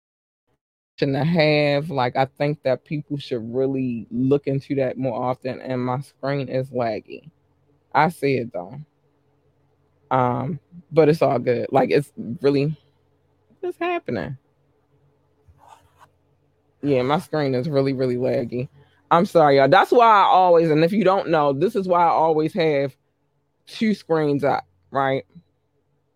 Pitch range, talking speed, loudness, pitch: 130-155 Hz, 140 wpm, -20 LUFS, 140 Hz